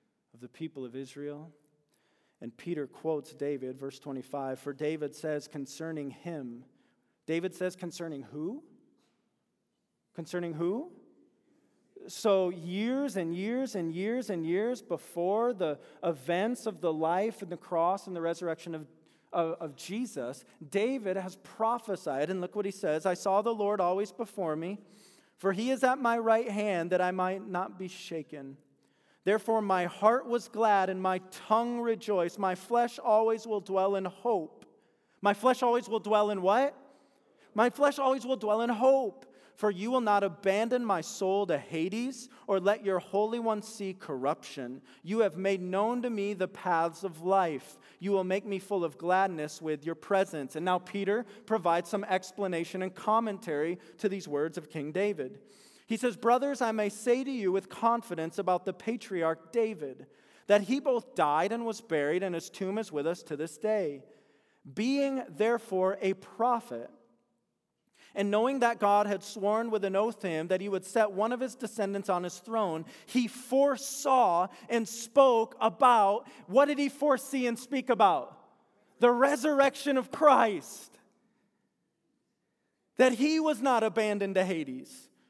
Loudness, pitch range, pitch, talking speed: -30 LUFS, 170-230 Hz, 195 Hz, 165 wpm